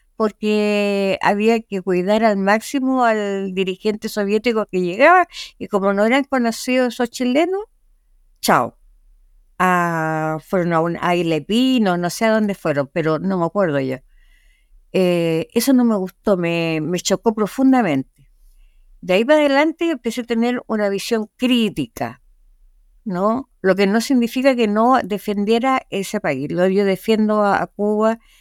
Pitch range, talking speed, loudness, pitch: 175-235 Hz, 145 wpm, -18 LUFS, 205 Hz